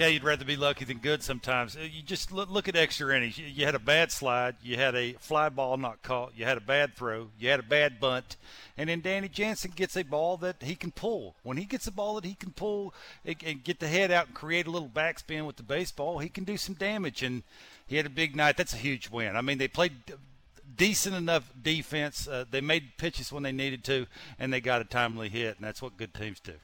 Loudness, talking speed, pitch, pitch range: -30 LUFS, 250 wpm, 145 Hz, 130-170 Hz